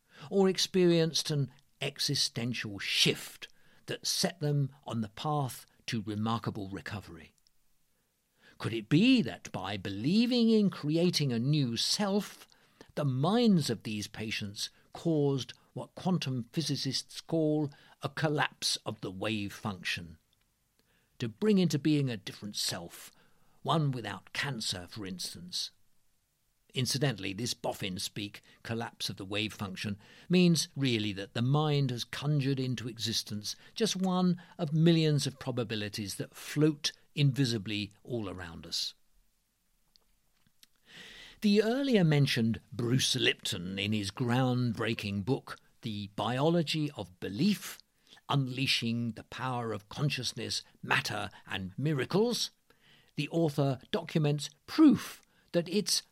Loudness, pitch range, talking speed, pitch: -31 LUFS, 110-160 Hz, 120 wpm, 130 Hz